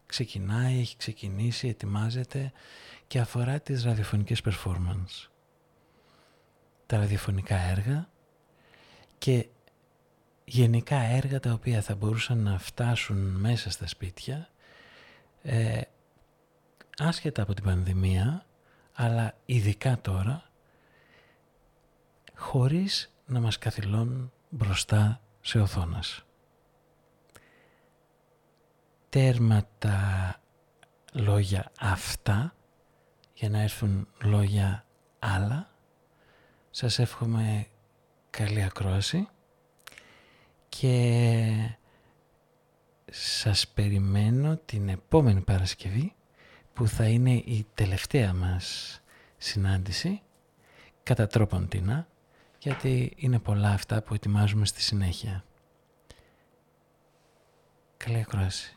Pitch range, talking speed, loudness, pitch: 100-135 Hz, 80 wpm, -28 LUFS, 115 Hz